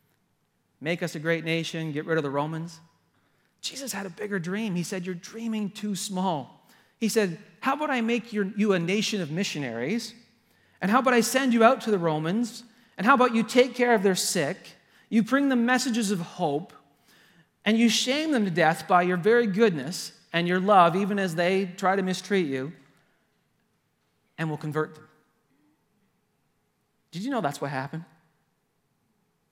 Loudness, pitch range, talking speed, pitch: -25 LUFS, 165-230 Hz, 180 wpm, 195 Hz